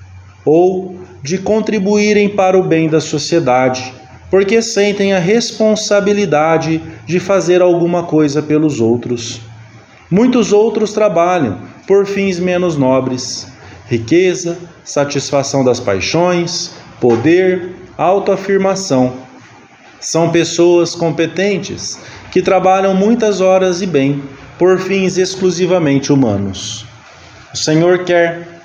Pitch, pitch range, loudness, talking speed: 170 Hz, 135-190 Hz, -13 LUFS, 100 wpm